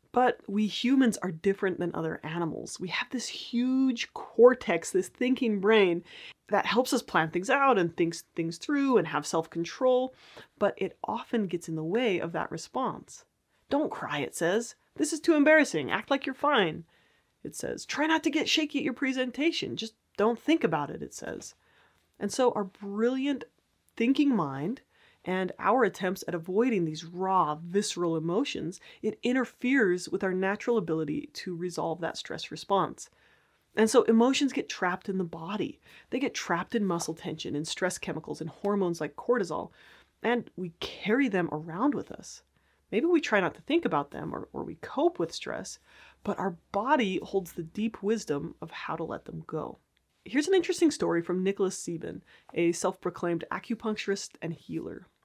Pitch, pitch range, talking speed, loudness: 205 Hz, 175-255 Hz, 175 wpm, -29 LUFS